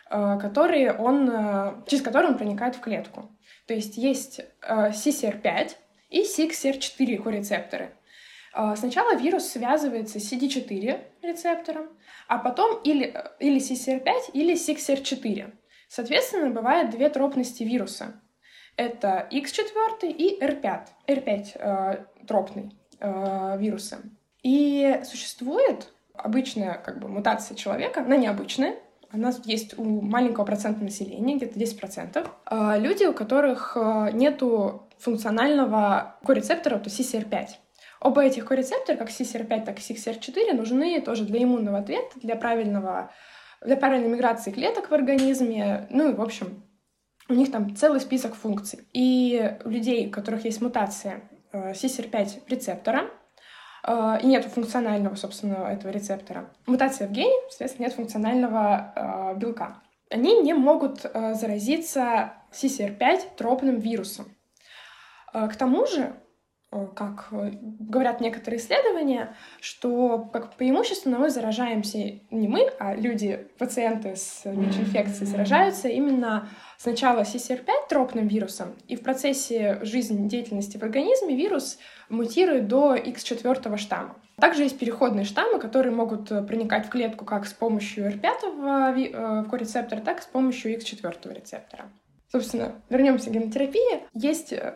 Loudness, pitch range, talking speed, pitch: -25 LUFS, 210-270 Hz, 125 wpm, 235 Hz